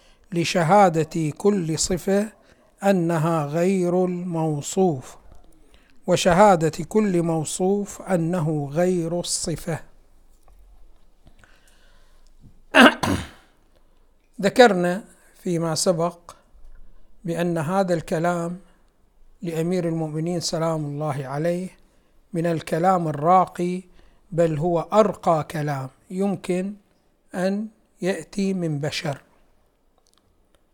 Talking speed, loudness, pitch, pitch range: 70 wpm, -22 LUFS, 175 Hz, 160-185 Hz